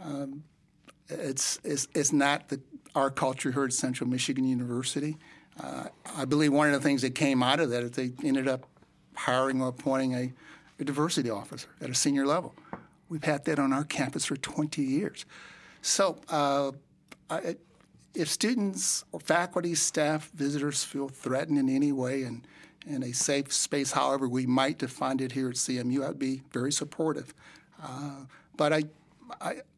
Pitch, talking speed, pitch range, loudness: 140 Hz, 170 wpm, 130-150 Hz, -29 LUFS